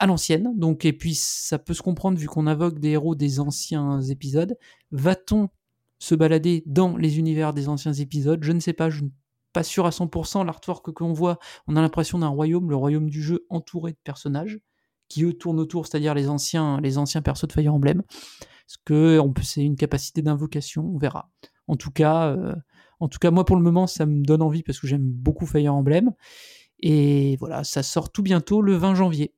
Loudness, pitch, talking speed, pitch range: -23 LUFS, 160 Hz, 215 wpm, 150-175 Hz